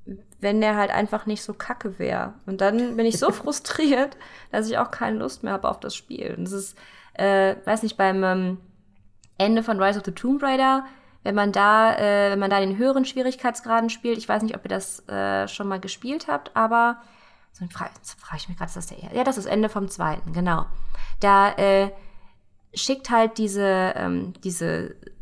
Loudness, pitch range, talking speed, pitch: -23 LUFS, 190-230 Hz, 200 wpm, 205 Hz